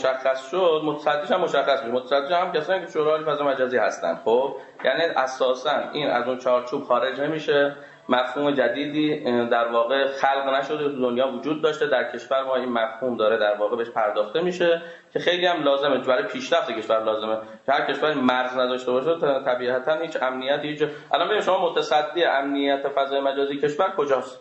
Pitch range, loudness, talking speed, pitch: 125-150 Hz, -23 LUFS, 175 wpm, 135 Hz